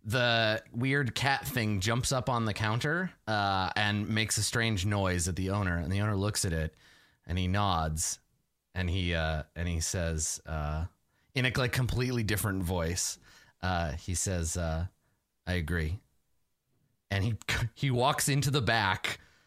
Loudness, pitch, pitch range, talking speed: -31 LUFS, 100 Hz, 85-120 Hz, 165 wpm